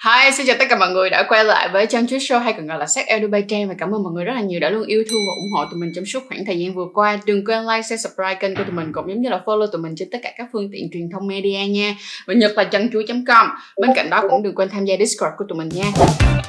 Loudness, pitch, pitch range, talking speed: -18 LUFS, 205 Hz, 185-225 Hz, 320 wpm